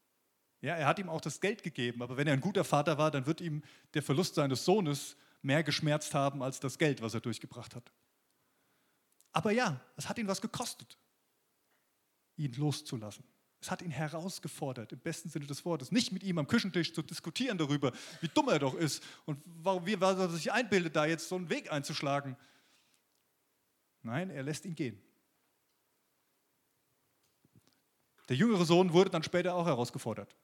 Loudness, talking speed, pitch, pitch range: -34 LUFS, 175 wpm, 160 Hz, 140-180 Hz